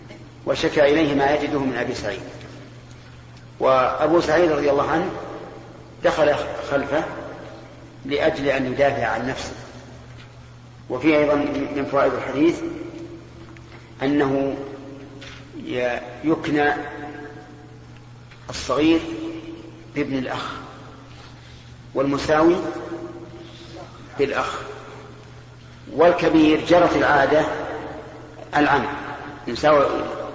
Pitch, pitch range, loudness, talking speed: 140 Hz, 120-150 Hz, -21 LUFS, 70 wpm